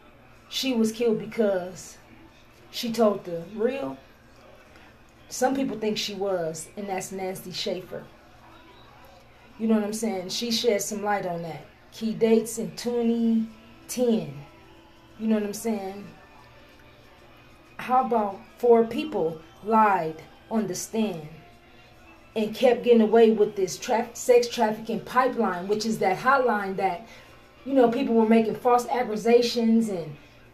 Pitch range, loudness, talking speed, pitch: 185-230 Hz, -25 LUFS, 135 wpm, 215 Hz